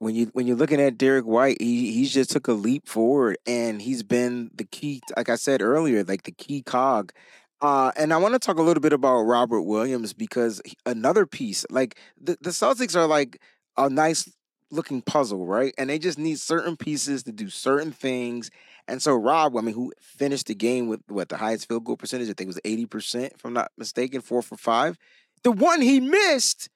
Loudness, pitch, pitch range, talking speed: -24 LUFS, 135 Hz, 115-160 Hz, 220 wpm